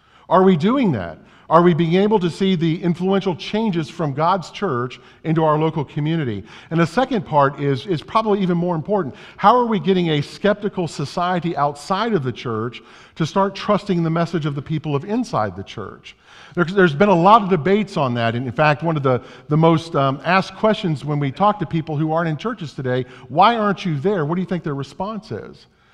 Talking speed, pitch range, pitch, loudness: 215 wpm, 145-195 Hz, 170 Hz, -19 LUFS